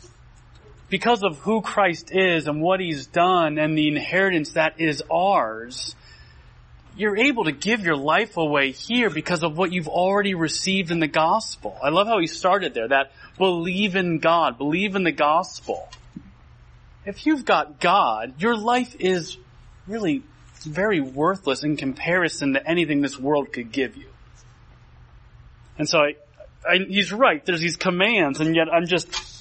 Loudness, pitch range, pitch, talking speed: -22 LUFS, 150-190 Hz, 170 Hz, 160 wpm